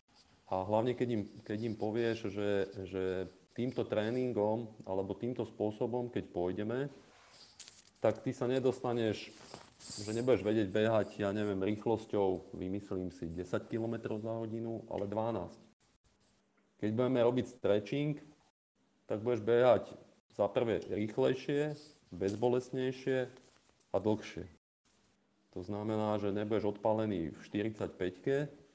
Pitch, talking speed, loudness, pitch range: 110 Hz, 115 wpm, -35 LUFS, 100-125 Hz